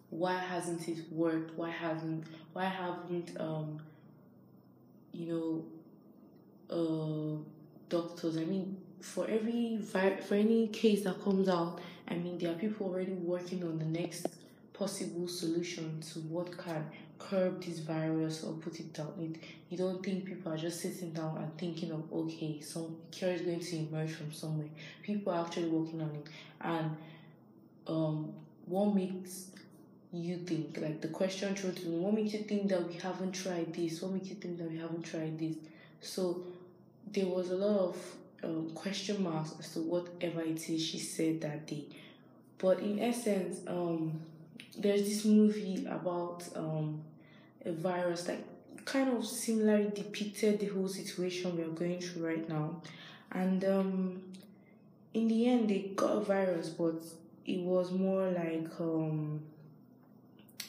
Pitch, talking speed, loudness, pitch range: 175 Hz, 160 wpm, -36 LUFS, 160-190 Hz